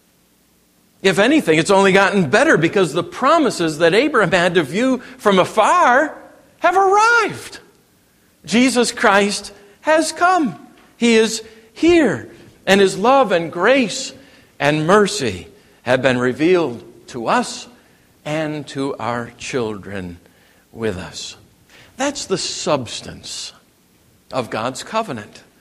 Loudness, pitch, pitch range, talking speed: -16 LUFS, 195 Hz, 155-245 Hz, 115 wpm